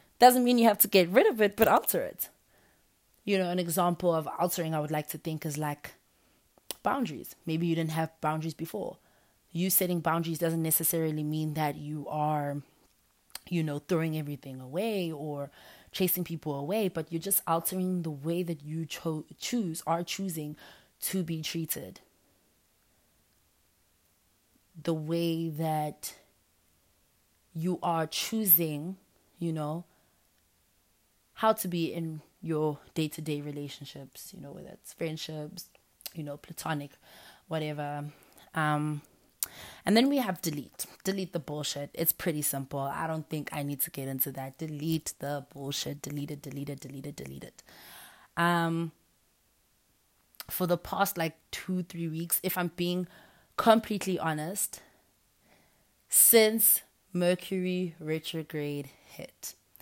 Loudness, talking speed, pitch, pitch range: -30 LUFS, 140 wpm, 160 Hz, 150-175 Hz